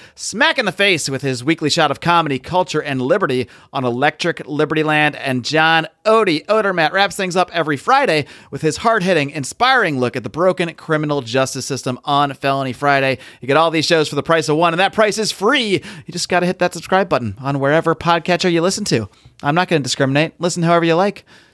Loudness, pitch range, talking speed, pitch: -16 LUFS, 140-180 Hz, 210 wpm, 160 Hz